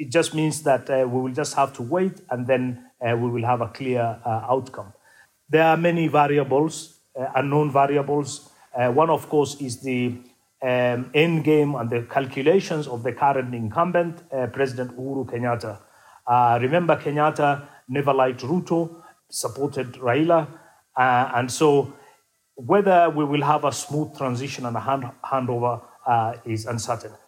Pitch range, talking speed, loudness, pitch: 125-150 Hz, 160 wpm, -22 LUFS, 135 Hz